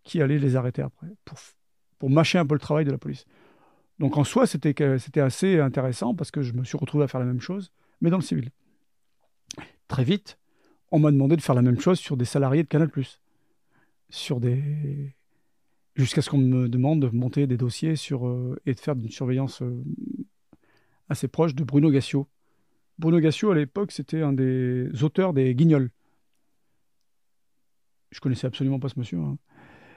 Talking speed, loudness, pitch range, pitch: 185 wpm, -24 LUFS, 130-155 Hz, 140 Hz